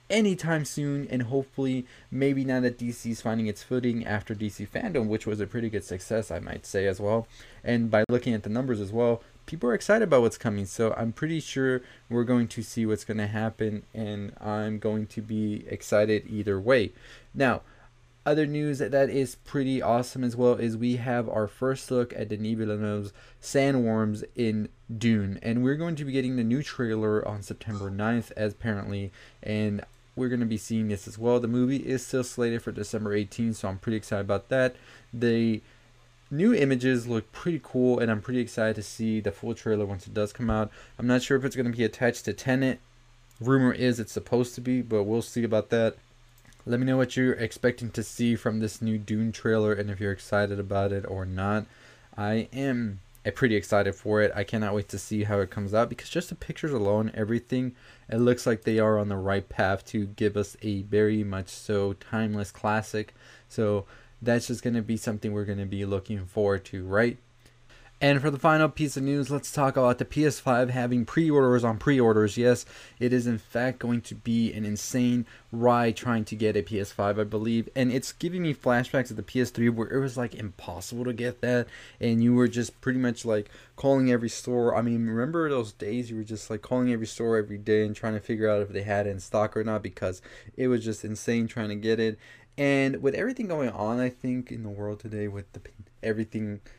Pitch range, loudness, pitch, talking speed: 105-125 Hz, -28 LUFS, 115 Hz, 215 wpm